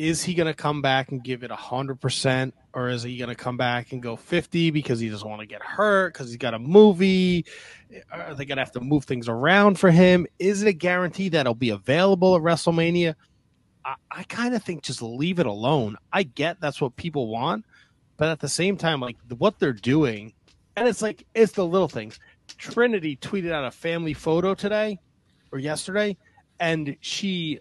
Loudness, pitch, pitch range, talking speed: -23 LUFS, 155 Hz, 130-185 Hz, 210 wpm